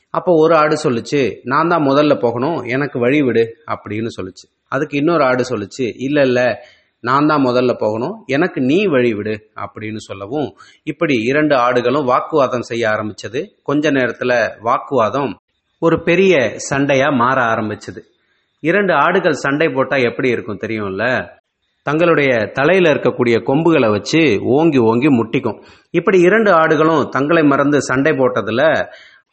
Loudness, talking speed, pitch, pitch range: -15 LUFS, 135 wpm, 135 Hz, 120-160 Hz